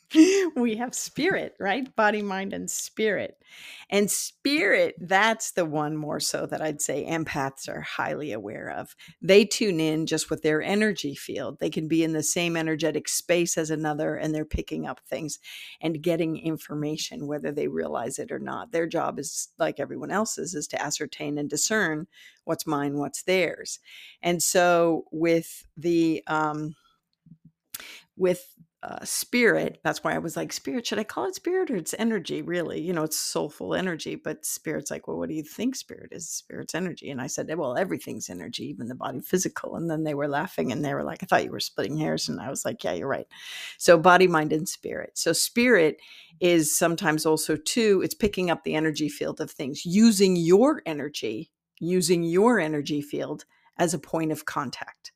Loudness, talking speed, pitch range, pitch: -26 LUFS, 190 wpm, 155-200 Hz, 170 Hz